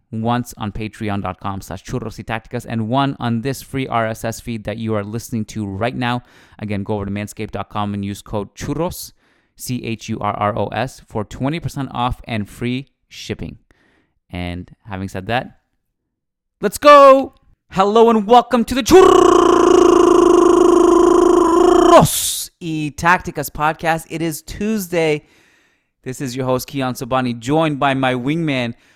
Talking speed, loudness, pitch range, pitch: 145 wpm, -16 LUFS, 110-175 Hz, 130 Hz